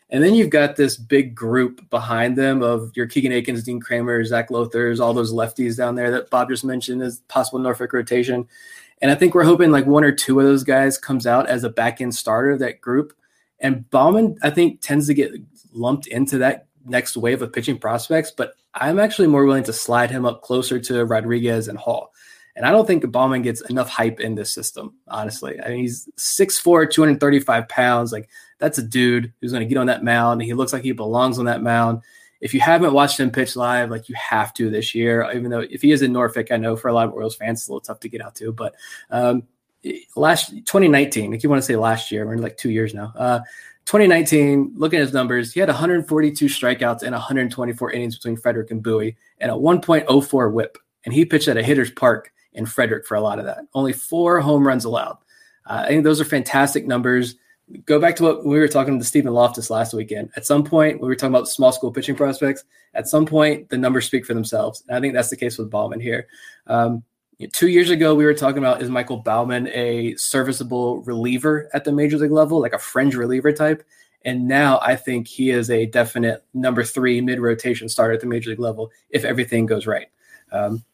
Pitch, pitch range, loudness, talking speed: 125 Hz, 120-140 Hz, -19 LUFS, 235 wpm